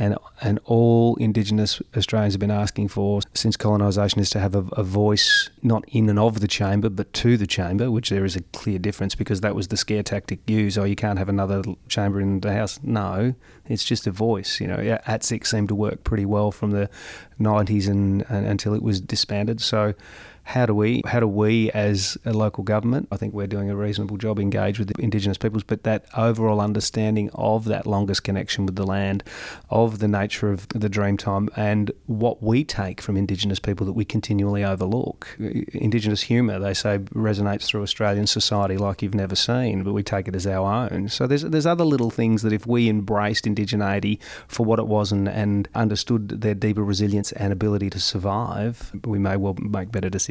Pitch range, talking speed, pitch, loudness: 100-110 Hz, 205 wpm, 105 Hz, -23 LUFS